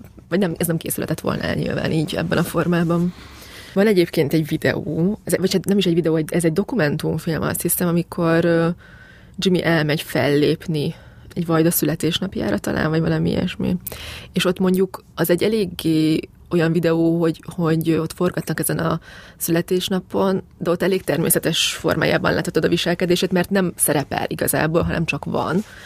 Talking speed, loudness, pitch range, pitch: 155 wpm, -20 LUFS, 160-180 Hz, 170 Hz